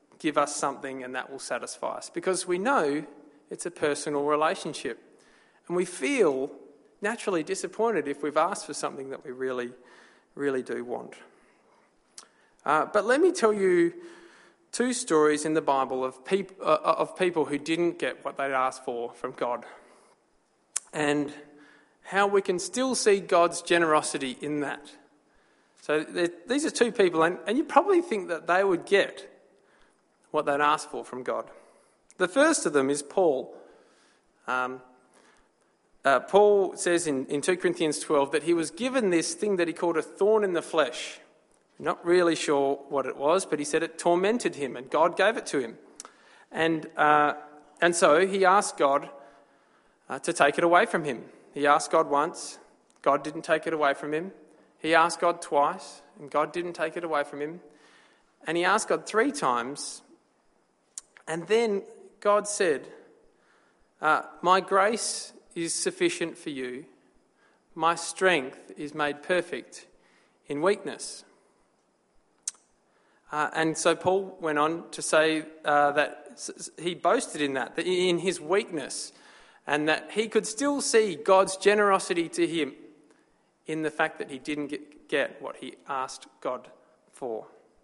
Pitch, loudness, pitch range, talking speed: 160 Hz, -27 LUFS, 145-195 Hz, 160 wpm